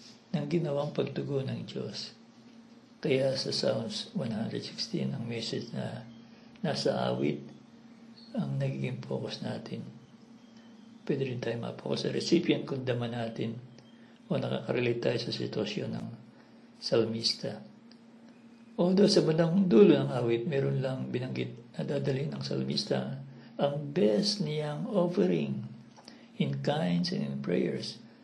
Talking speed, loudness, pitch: 120 wpm, -31 LUFS, 140 Hz